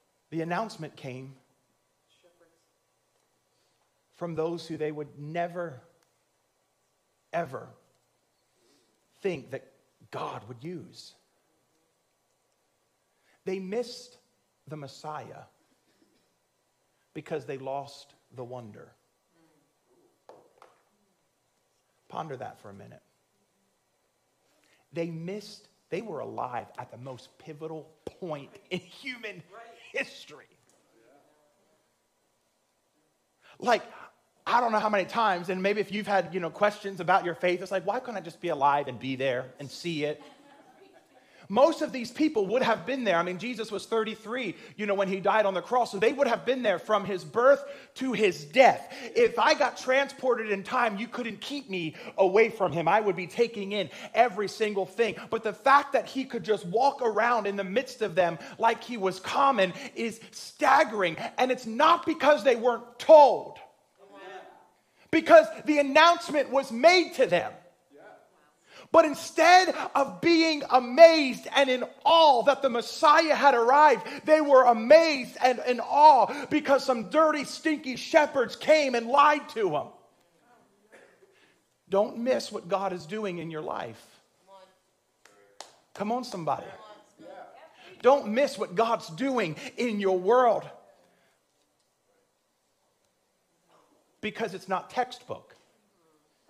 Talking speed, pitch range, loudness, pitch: 135 wpm, 180-265 Hz, -25 LUFS, 220 Hz